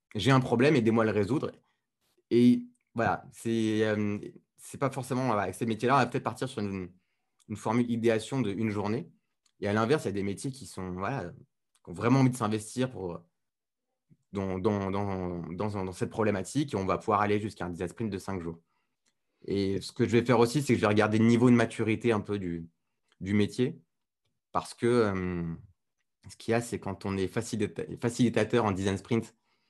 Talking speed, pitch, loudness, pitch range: 210 wpm, 110 Hz, -29 LUFS, 95-120 Hz